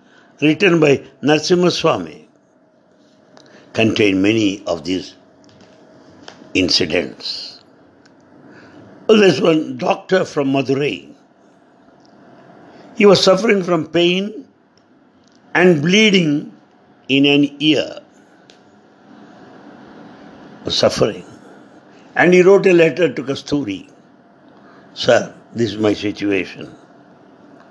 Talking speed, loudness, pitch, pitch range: 90 wpm, -15 LUFS, 155 Hz, 135-190 Hz